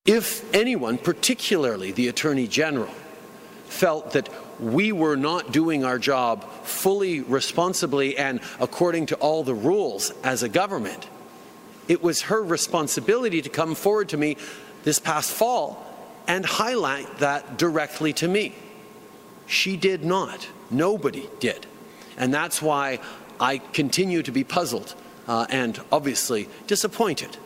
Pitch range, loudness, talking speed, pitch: 140-190 Hz, -24 LUFS, 130 wpm, 155 Hz